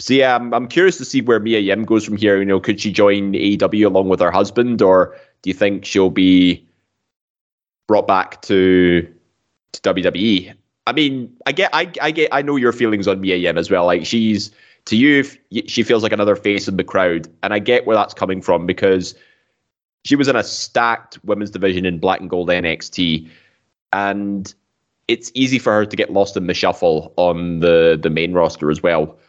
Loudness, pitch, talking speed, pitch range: -16 LUFS, 100 Hz, 205 wpm, 90-115 Hz